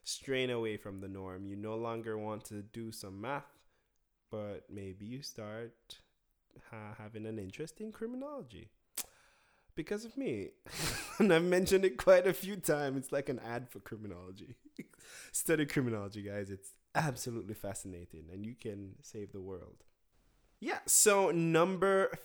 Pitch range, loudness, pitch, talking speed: 100-160 Hz, -34 LUFS, 115 Hz, 150 wpm